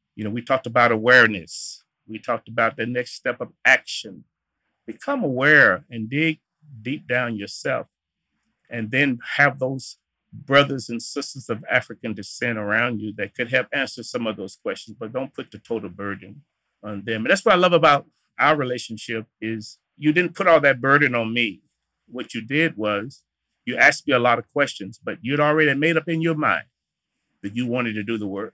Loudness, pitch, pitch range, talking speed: -21 LUFS, 125 Hz, 110-145 Hz, 195 wpm